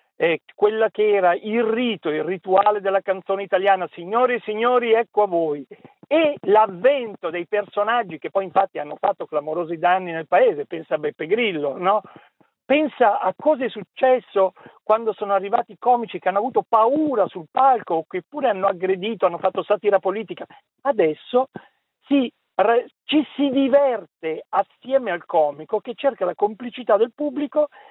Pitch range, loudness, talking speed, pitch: 190-255 Hz, -21 LUFS, 160 wpm, 210 Hz